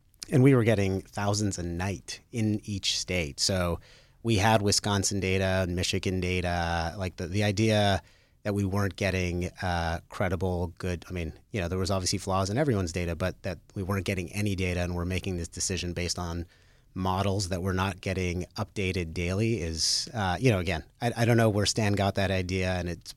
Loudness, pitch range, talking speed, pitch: -28 LUFS, 90-105 Hz, 200 wpm, 95 Hz